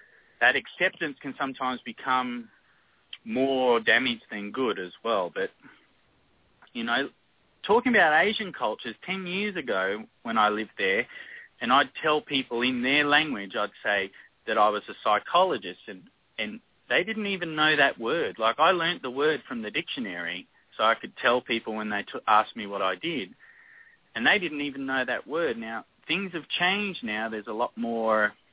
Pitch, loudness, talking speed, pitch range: 145 Hz, -26 LUFS, 175 wpm, 120-195 Hz